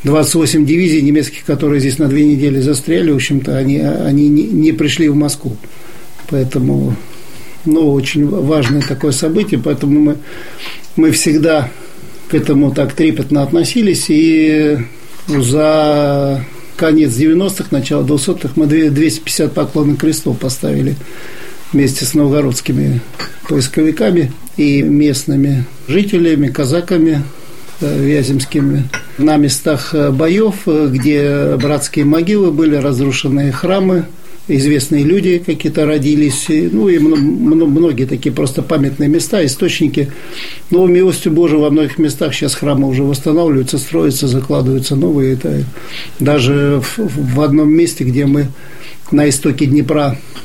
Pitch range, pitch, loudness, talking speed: 140-160 Hz, 150 Hz, -13 LUFS, 115 wpm